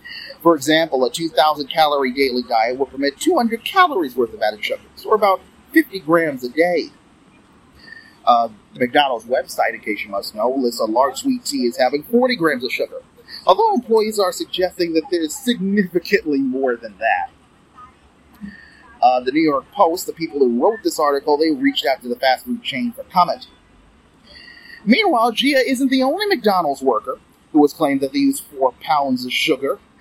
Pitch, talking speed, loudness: 195 Hz, 185 wpm, -18 LUFS